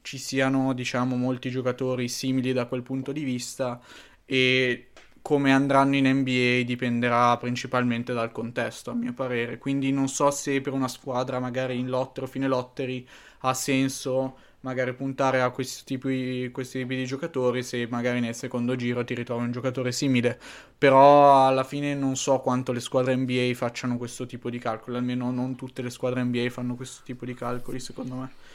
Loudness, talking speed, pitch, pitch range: -25 LUFS, 175 wpm, 130 Hz, 125-135 Hz